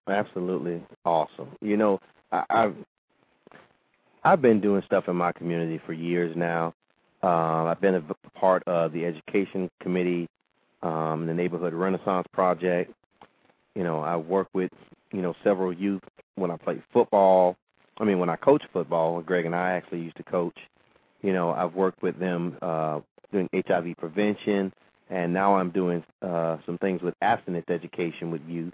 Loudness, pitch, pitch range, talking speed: -26 LUFS, 90 Hz, 85-95 Hz, 165 wpm